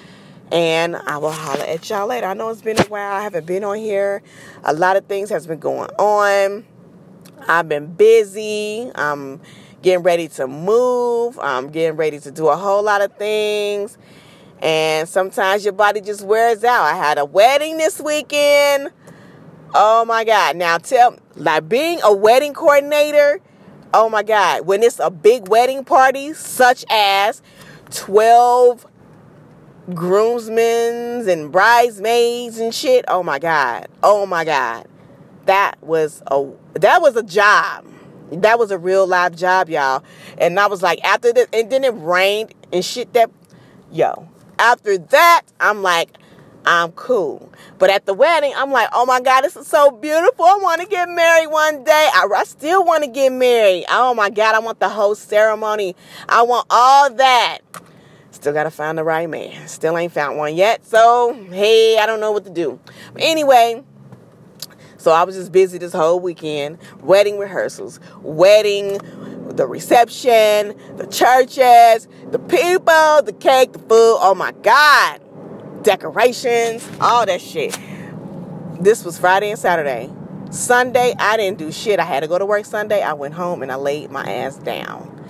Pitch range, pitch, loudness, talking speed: 175-240 Hz, 205 Hz, -15 LUFS, 170 wpm